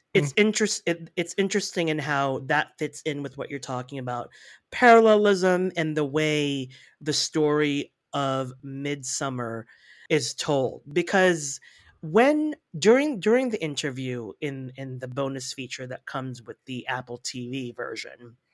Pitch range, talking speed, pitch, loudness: 130-175 Hz, 140 wpm, 145 Hz, -25 LUFS